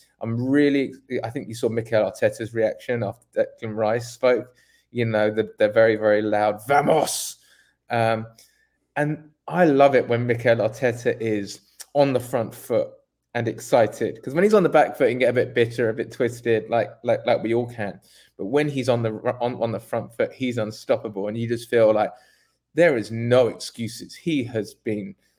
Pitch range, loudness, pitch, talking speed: 110-130 Hz, -23 LUFS, 115 Hz, 195 wpm